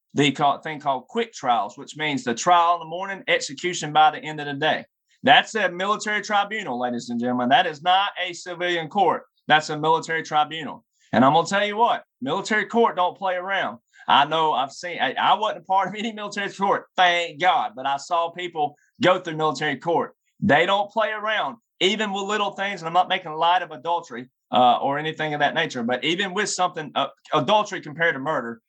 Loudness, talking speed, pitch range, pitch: -22 LUFS, 210 wpm, 150-200 Hz, 175 Hz